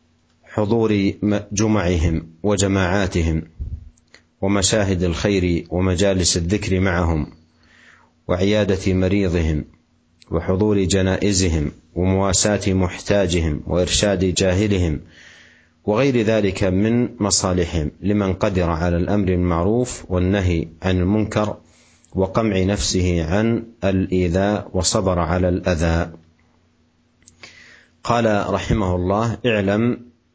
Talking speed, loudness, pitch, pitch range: 75 wpm, -19 LUFS, 95 Hz, 85-100 Hz